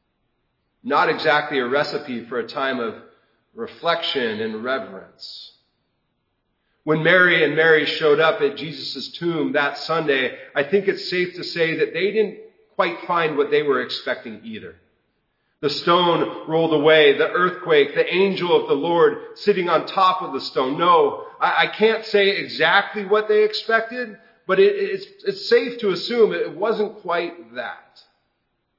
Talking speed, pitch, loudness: 150 wpm, 210 Hz, -20 LUFS